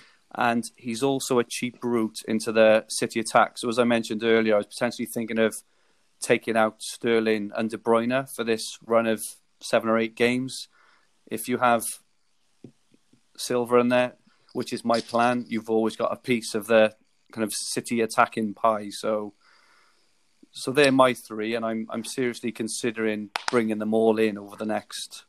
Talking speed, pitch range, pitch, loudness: 175 wpm, 110-120 Hz, 115 Hz, -25 LUFS